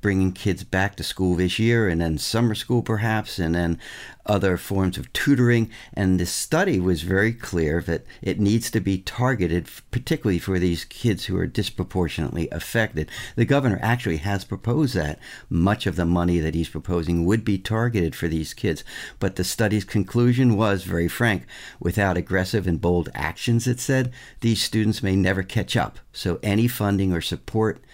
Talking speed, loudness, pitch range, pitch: 175 wpm, -23 LUFS, 85-110 Hz, 95 Hz